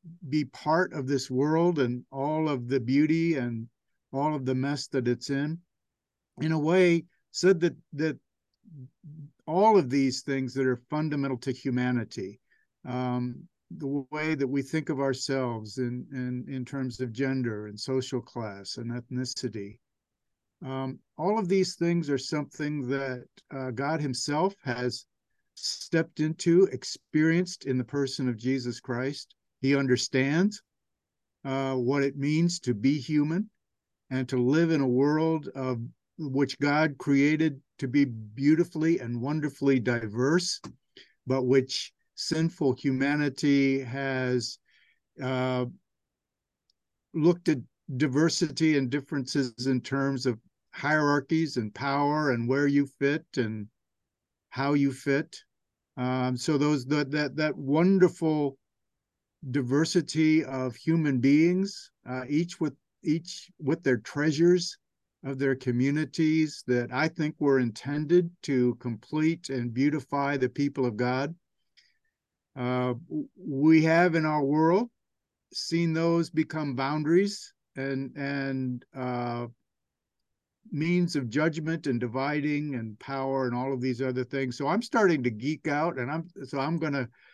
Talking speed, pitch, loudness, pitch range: 135 wpm, 140 Hz, -28 LUFS, 130-155 Hz